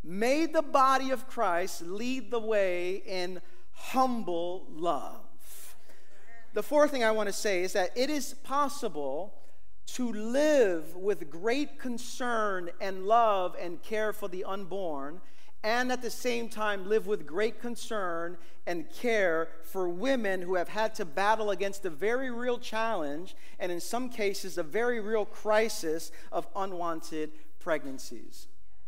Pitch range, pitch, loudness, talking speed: 180-240 Hz, 210 Hz, -31 LUFS, 145 wpm